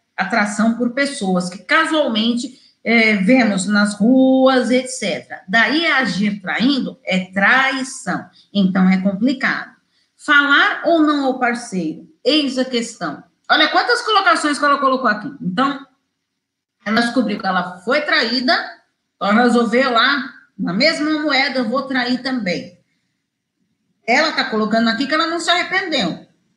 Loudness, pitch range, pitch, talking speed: -16 LUFS, 215-280 Hz, 255 Hz, 135 wpm